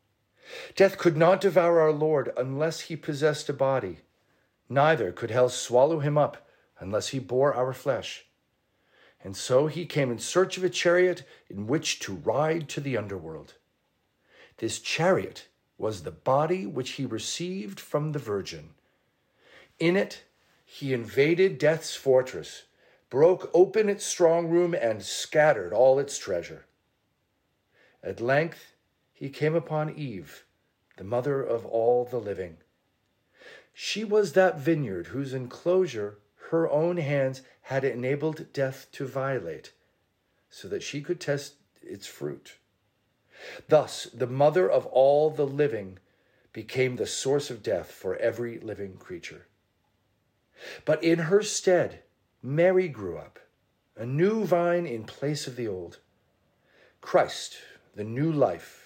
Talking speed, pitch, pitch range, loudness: 135 wpm, 145 Hz, 125-170 Hz, -26 LUFS